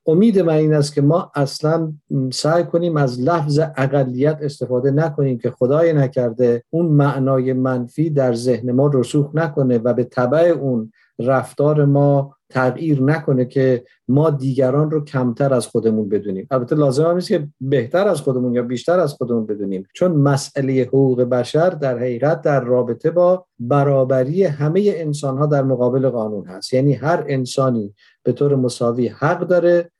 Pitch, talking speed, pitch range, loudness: 135 Hz, 160 wpm, 125-155 Hz, -18 LUFS